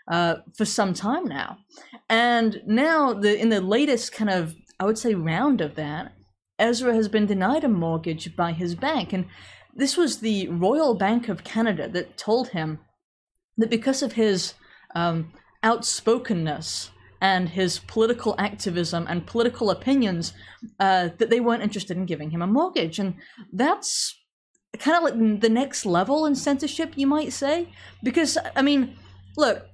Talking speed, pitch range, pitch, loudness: 160 wpm, 175-255 Hz, 215 Hz, -24 LUFS